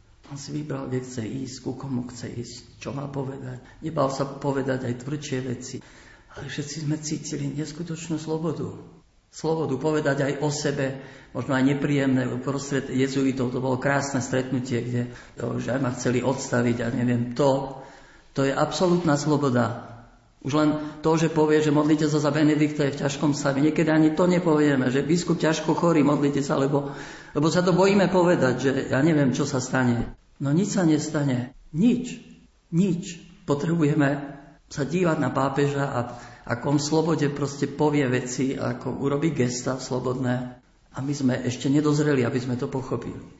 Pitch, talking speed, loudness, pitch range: 140 Hz, 165 wpm, -24 LUFS, 130-150 Hz